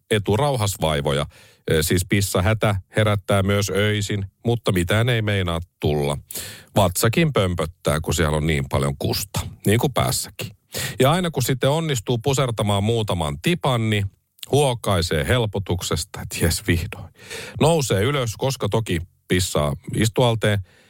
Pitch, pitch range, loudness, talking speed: 105 Hz, 90-120 Hz, -21 LUFS, 125 wpm